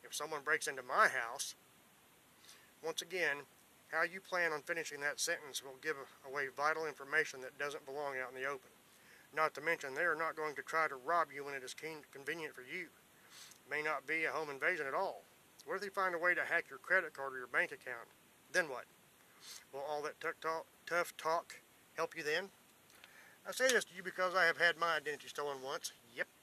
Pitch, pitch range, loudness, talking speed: 155 Hz, 140-170 Hz, -38 LUFS, 210 wpm